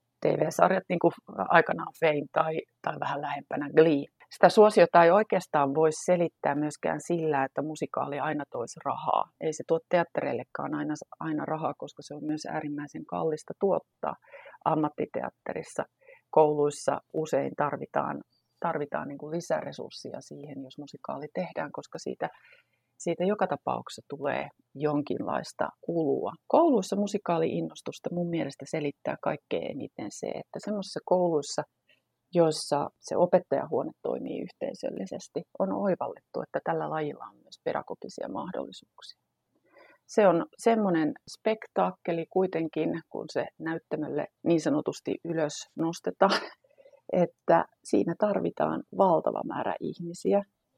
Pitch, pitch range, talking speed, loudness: 165 Hz, 150-185 Hz, 115 wpm, -29 LUFS